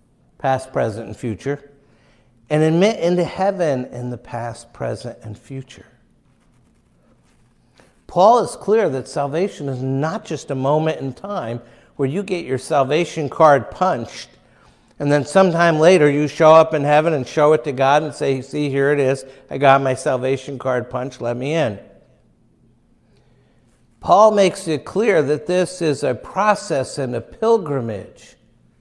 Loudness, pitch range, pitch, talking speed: -18 LUFS, 125-155 Hz, 140 Hz, 155 wpm